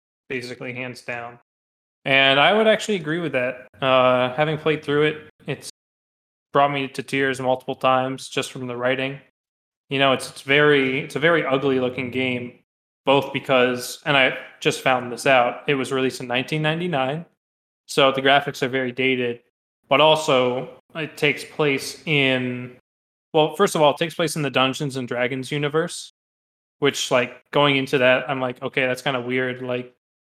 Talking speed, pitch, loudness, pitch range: 175 wpm, 130 Hz, -21 LUFS, 125-145 Hz